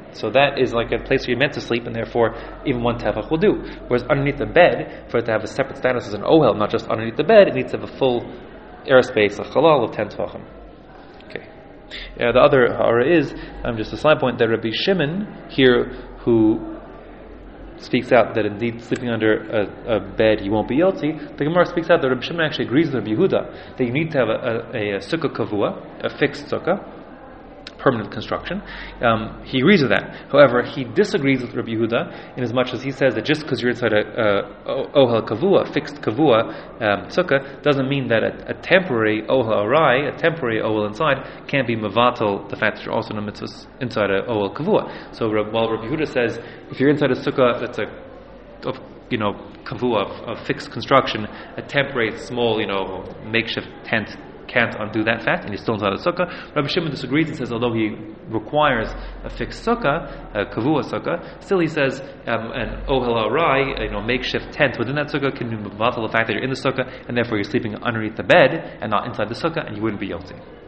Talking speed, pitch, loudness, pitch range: 215 wpm, 120 Hz, -20 LUFS, 110-140 Hz